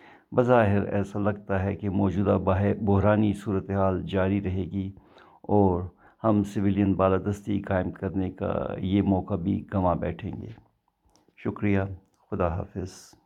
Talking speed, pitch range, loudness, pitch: 125 wpm, 95-100 Hz, -26 LUFS, 100 Hz